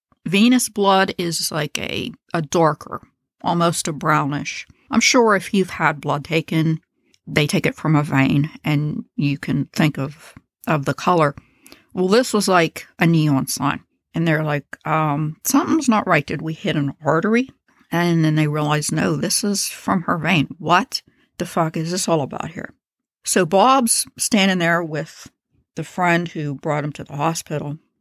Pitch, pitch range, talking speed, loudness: 165 Hz, 150-195 Hz, 175 wpm, -19 LUFS